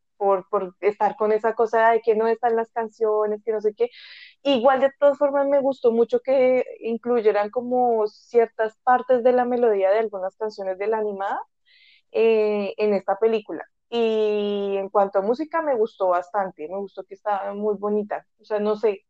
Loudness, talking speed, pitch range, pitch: -22 LUFS, 185 wpm, 205-250 Hz, 220 Hz